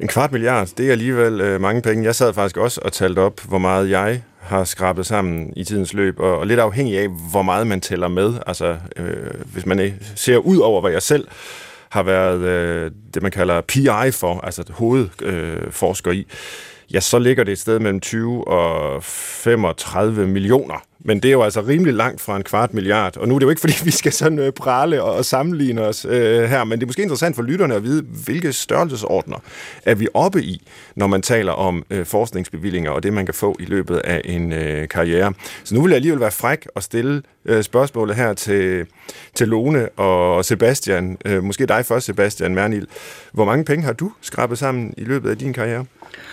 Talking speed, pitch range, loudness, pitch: 205 wpm, 95-125 Hz, -18 LUFS, 105 Hz